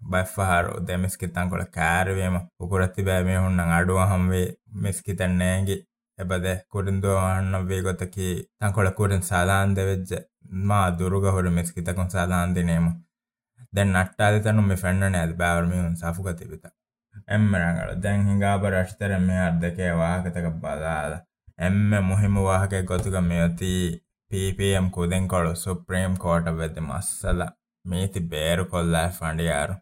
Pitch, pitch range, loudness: 90 Hz, 90-95 Hz, -24 LUFS